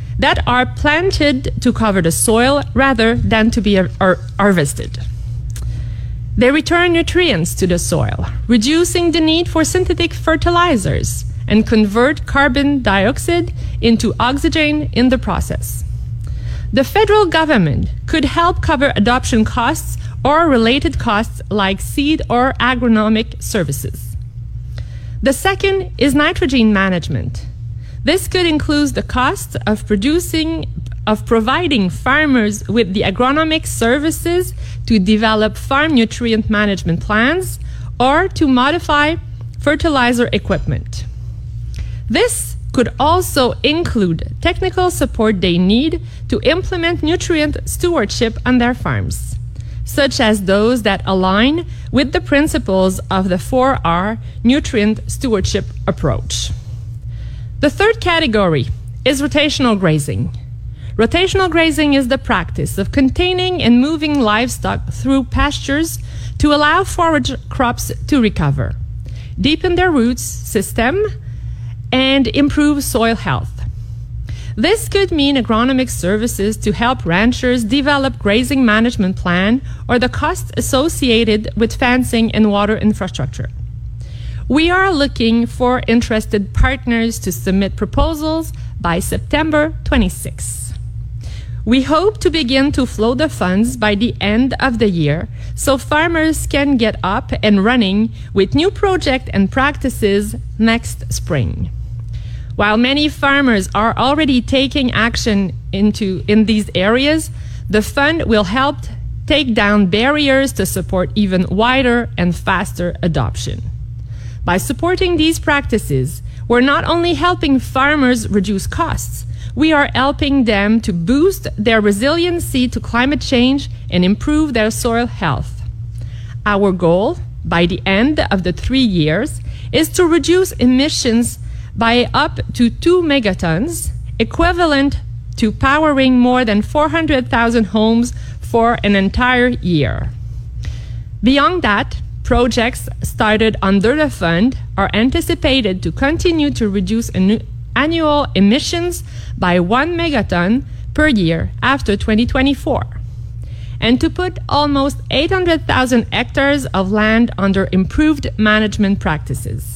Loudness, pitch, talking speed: -15 LUFS, 230 Hz, 120 wpm